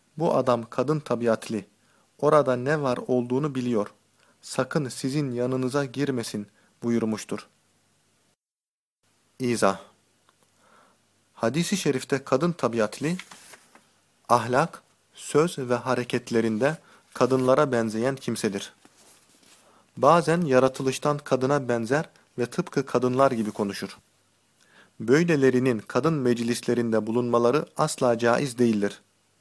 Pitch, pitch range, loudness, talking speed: 125 Hz, 120-140 Hz, -25 LUFS, 85 wpm